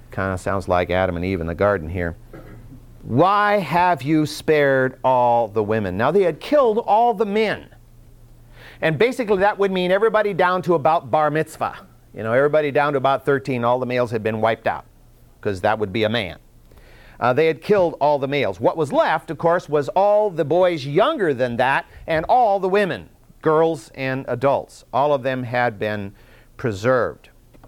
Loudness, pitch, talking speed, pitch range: -20 LUFS, 135 Hz, 190 wpm, 115-170 Hz